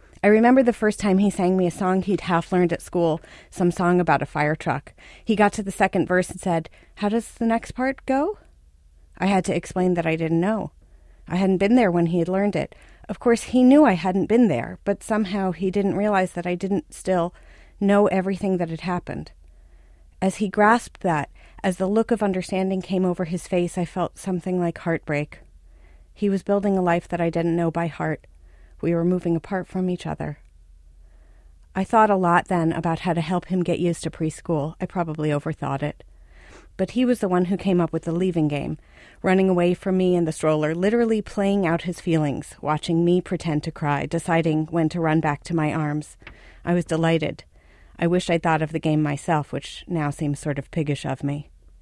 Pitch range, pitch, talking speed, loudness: 155-190 Hz, 175 Hz, 215 wpm, -22 LUFS